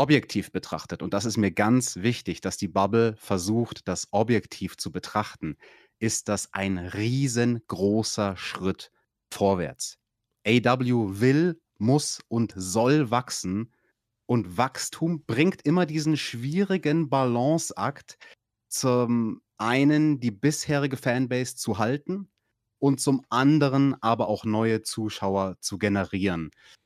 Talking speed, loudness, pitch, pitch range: 115 wpm, -26 LUFS, 120 Hz, 105-140 Hz